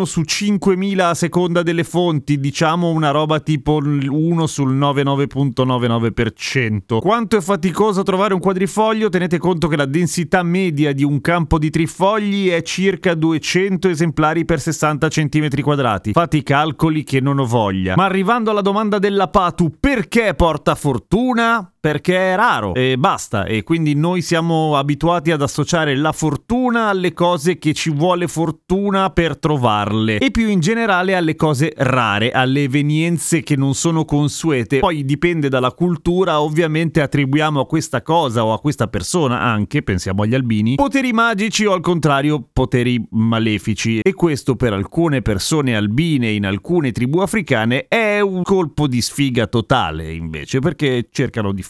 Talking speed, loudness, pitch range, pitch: 155 wpm, -17 LUFS, 135-180 Hz, 155 Hz